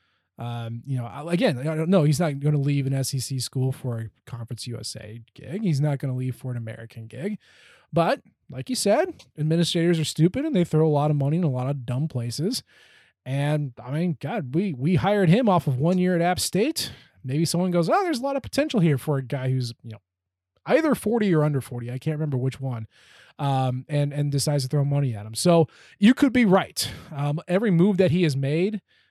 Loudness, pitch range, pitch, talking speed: -24 LUFS, 130-175 Hz, 150 Hz, 225 wpm